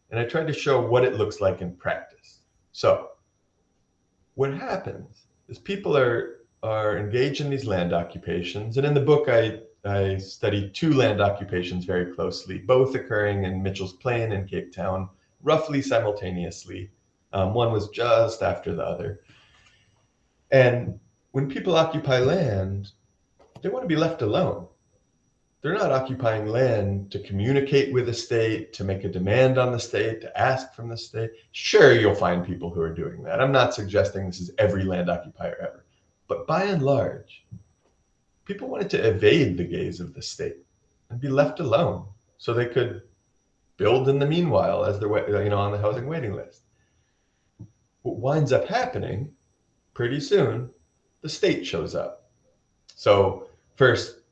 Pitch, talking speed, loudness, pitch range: 115 Hz, 160 wpm, -24 LUFS, 100-135 Hz